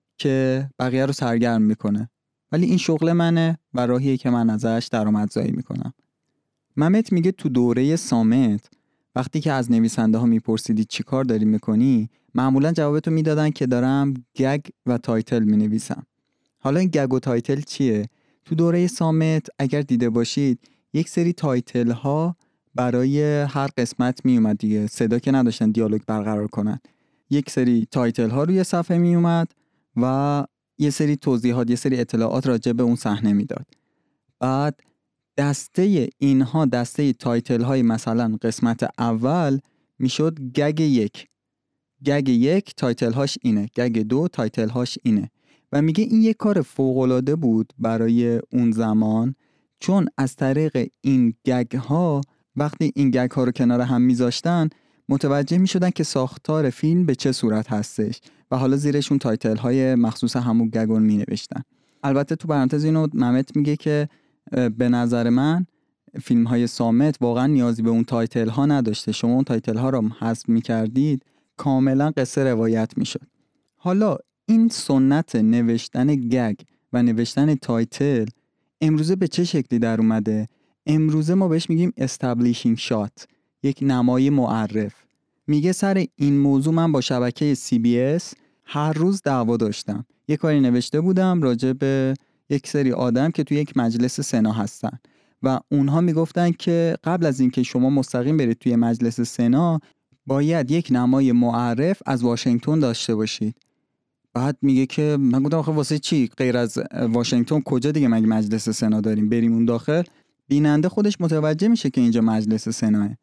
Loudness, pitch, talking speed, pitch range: -21 LUFS, 130 Hz, 150 wpm, 120-150 Hz